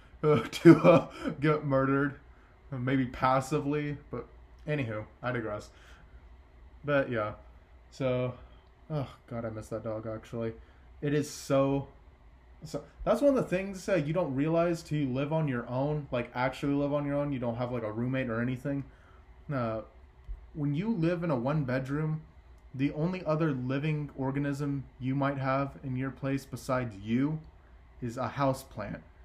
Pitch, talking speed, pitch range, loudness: 135 Hz, 160 wpm, 110-145 Hz, -31 LUFS